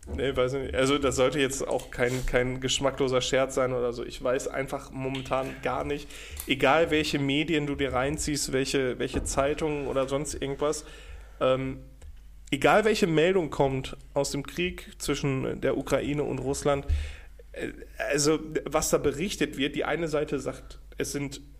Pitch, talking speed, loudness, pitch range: 140 Hz, 160 wpm, -28 LUFS, 130-145 Hz